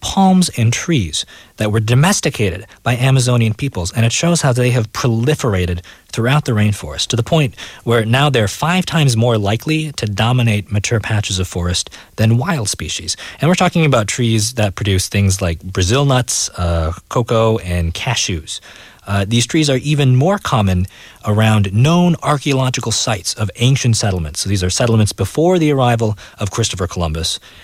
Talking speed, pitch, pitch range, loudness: 170 wpm, 115 Hz, 100-130 Hz, -15 LUFS